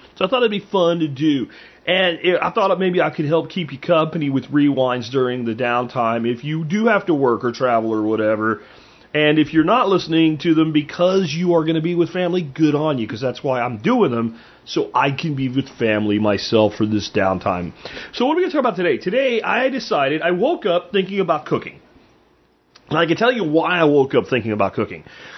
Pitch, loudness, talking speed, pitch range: 155 Hz, -19 LUFS, 225 wpm, 120-175 Hz